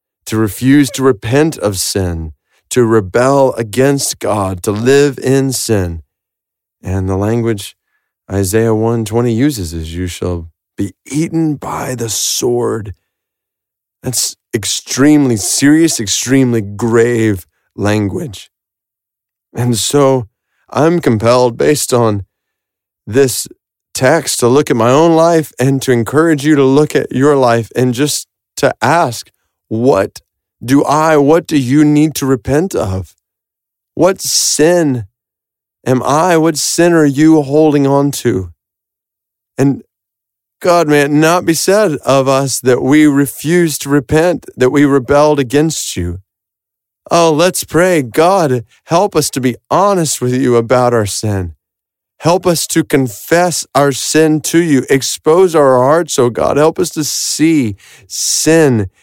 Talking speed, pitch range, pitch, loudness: 135 wpm, 110-150 Hz, 130 Hz, -12 LUFS